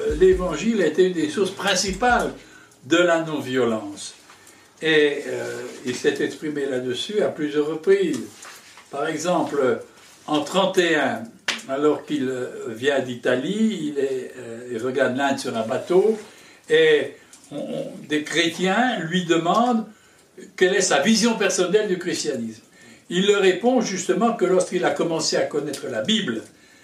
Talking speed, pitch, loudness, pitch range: 135 wpm, 185 Hz, -22 LUFS, 150-220 Hz